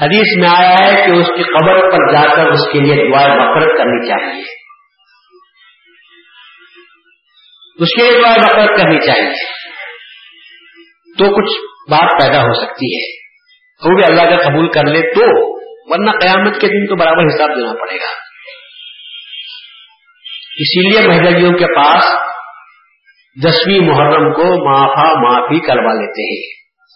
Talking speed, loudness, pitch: 140 wpm, -9 LUFS, 190 Hz